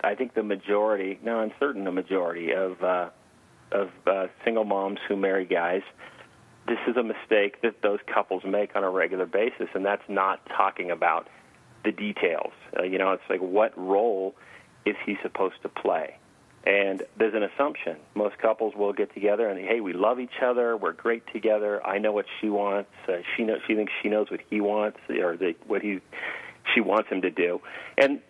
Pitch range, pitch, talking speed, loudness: 95-110 Hz, 105 Hz, 195 wpm, -27 LUFS